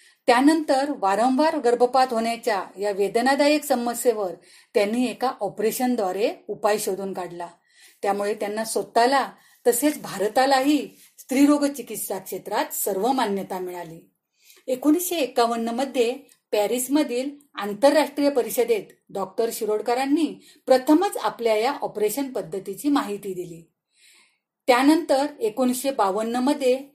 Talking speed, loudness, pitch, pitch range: 95 wpm, -23 LUFS, 240 Hz, 205-280 Hz